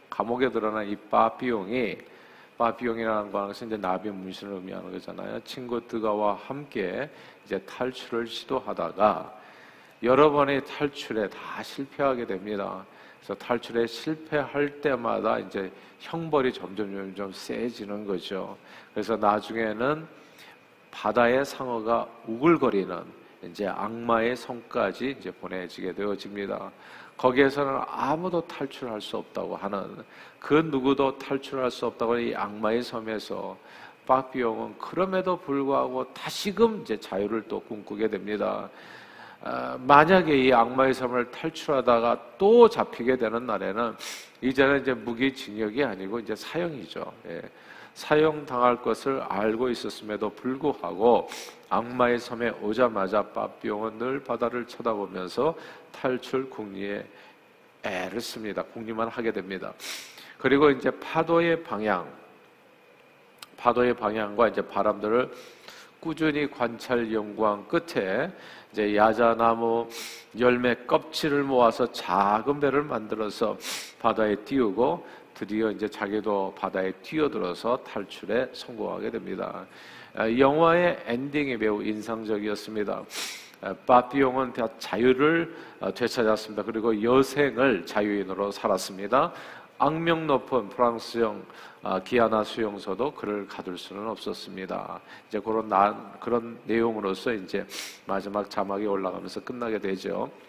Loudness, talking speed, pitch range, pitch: -27 LUFS, 285 characters per minute, 105-135 Hz, 115 Hz